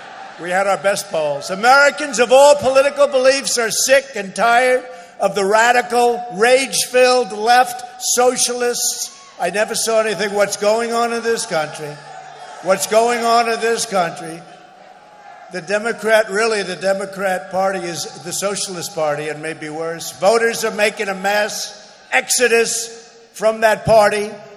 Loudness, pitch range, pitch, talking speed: -16 LUFS, 195-240 Hz, 220 Hz, 140 wpm